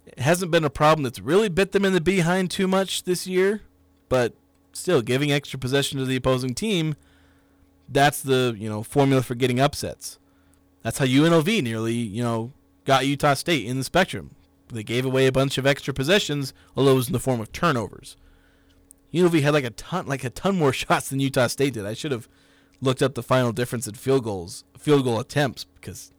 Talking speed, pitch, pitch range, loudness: 205 wpm, 130 Hz, 110-145 Hz, -23 LUFS